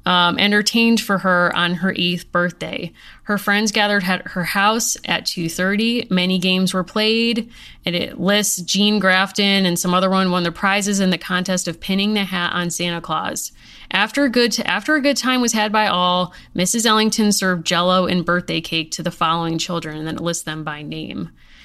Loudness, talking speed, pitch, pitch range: -18 LUFS, 200 wpm, 185 Hz, 175-210 Hz